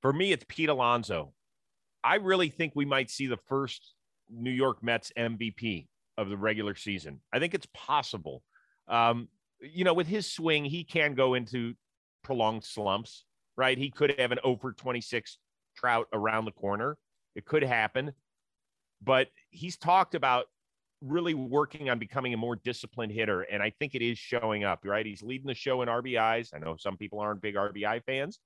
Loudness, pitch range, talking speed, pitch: -30 LUFS, 110-135 Hz, 180 wpm, 120 Hz